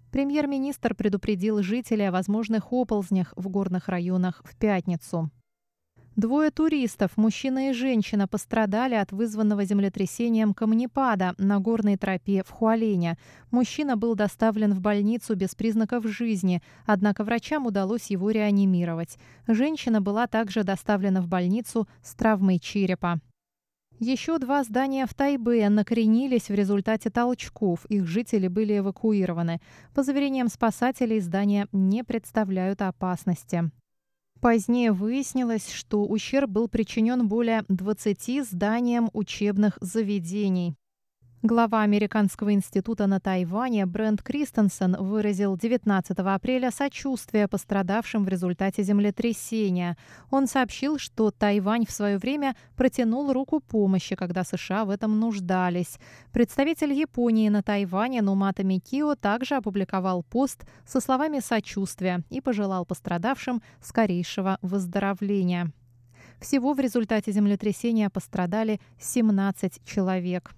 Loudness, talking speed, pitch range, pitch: -26 LUFS, 115 wpm, 190-235 Hz, 210 Hz